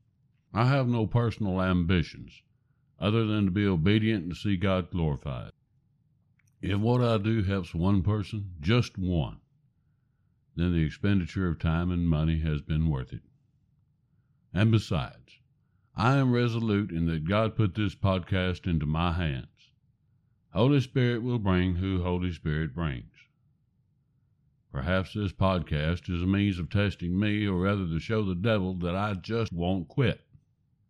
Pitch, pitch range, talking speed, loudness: 100 Hz, 90-120 Hz, 150 wpm, -28 LUFS